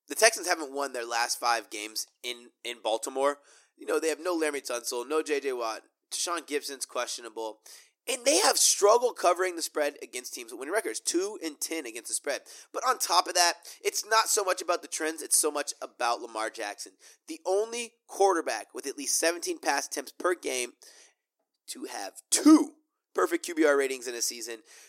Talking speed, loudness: 195 wpm, -28 LUFS